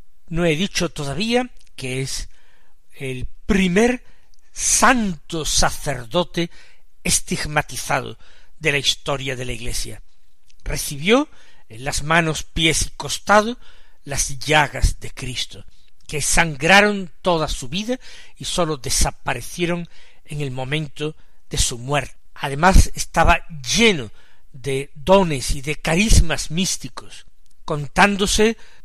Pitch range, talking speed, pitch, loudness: 135-180 Hz, 110 wpm, 155 Hz, -20 LUFS